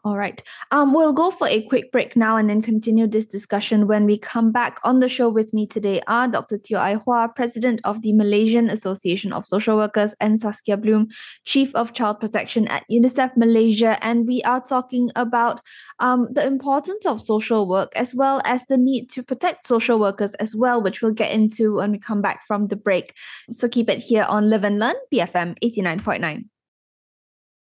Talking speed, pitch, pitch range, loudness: 200 wpm, 225 Hz, 210-245 Hz, -20 LUFS